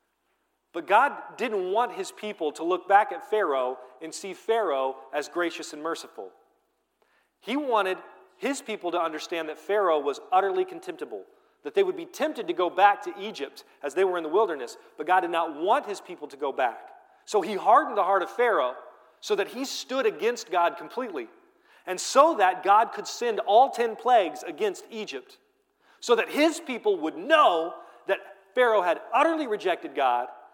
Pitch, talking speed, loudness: 245 Hz, 180 wpm, -26 LUFS